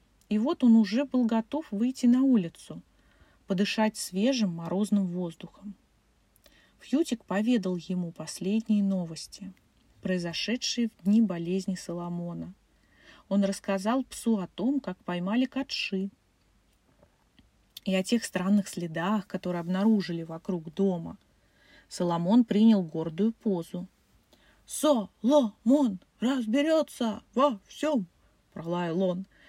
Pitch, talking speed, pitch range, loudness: 200 Hz, 100 wpm, 180-235 Hz, -28 LUFS